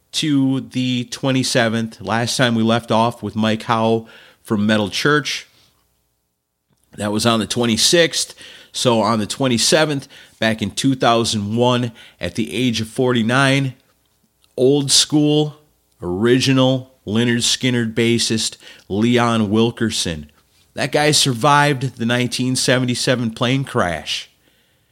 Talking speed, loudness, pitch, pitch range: 110 wpm, -17 LUFS, 120 Hz, 110-130 Hz